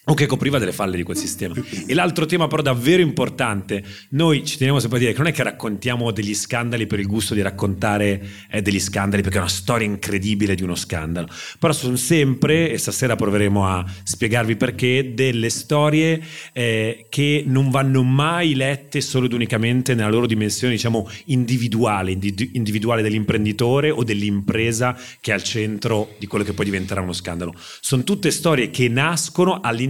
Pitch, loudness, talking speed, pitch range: 120 Hz, -20 LUFS, 185 wpm, 105-135 Hz